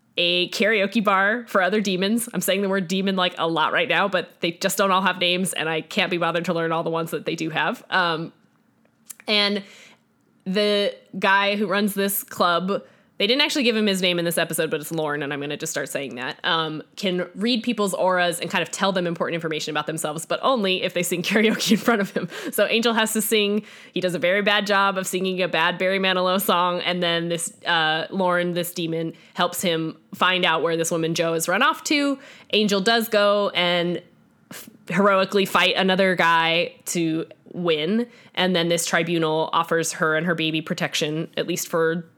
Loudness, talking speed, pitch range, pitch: -22 LUFS, 215 wpm, 165-205 Hz, 180 Hz